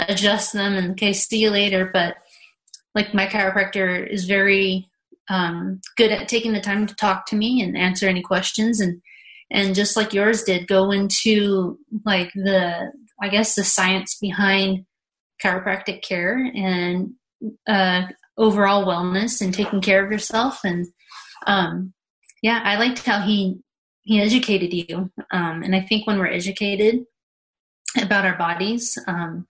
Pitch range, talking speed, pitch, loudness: 185-215 Hz, 150 wpm, 200 Hz, -20 LUFS